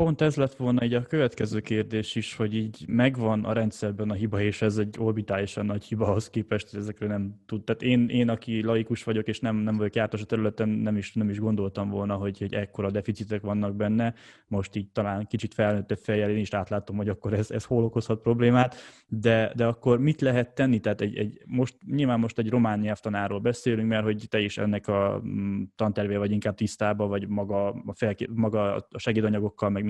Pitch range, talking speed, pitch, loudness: 105-115 Hz, 205 wpm, 110 Hz, -27 LUFS